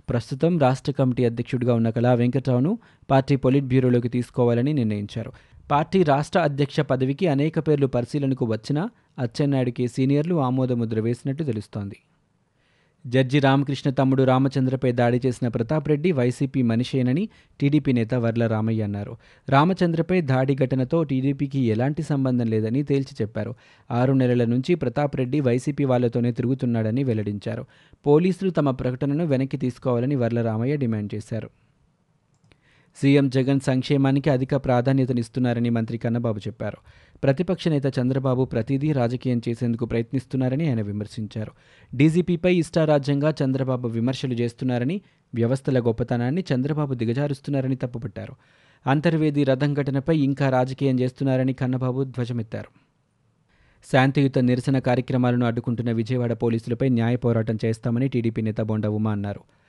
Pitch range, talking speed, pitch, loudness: 120-140 Hz, 115 wpm, 130 Hz, -23 LUFS